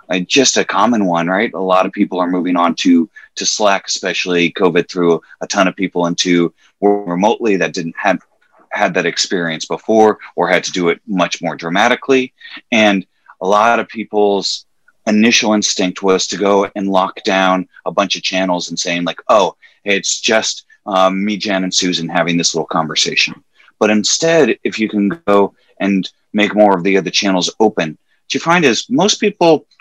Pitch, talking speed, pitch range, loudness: 95 Hz, 185 wpm, 90-105 Hz, -14 LUFS